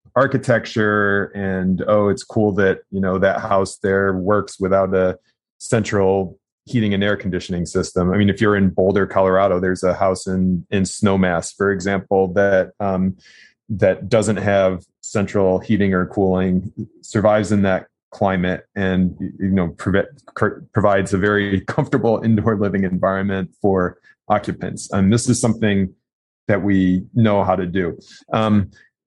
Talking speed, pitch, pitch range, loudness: 150 wpm, 95 Hz, 95-105 Hz, -18 LUFS